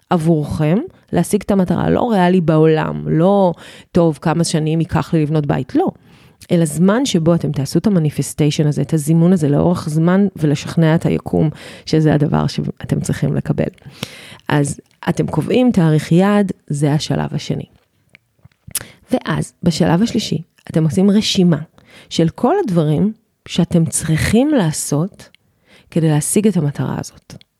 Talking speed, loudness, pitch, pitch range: 135 wpm, -16 LUFS, 165 Hz, 150-185 Hz